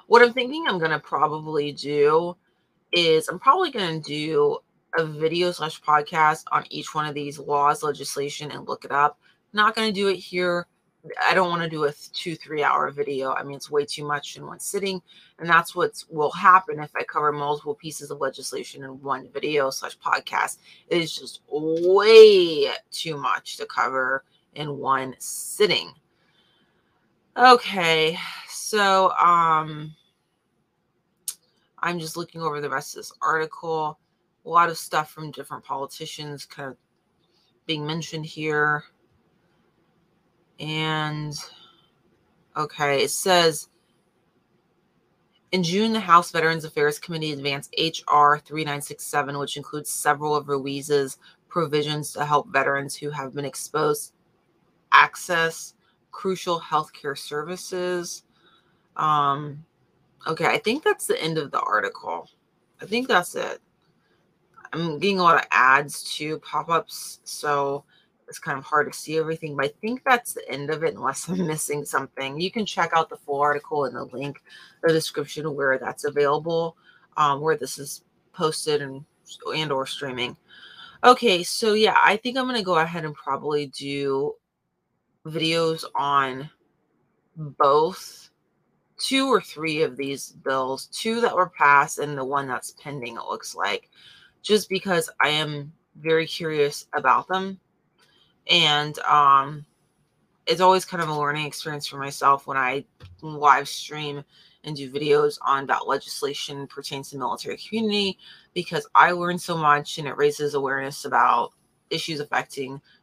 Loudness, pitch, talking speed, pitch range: -23 LUFS, 155 Hz, 150 wpm, 145-180 Hz